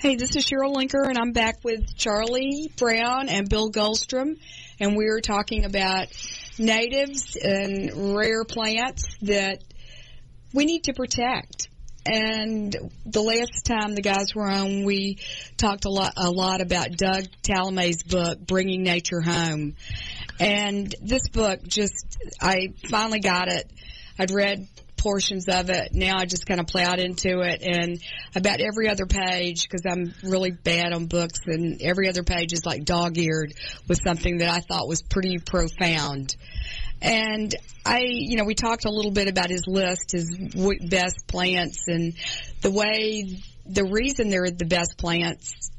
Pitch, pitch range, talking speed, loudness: 195 Hz, 175-215 Hz, 160 wpm, -24 LUFS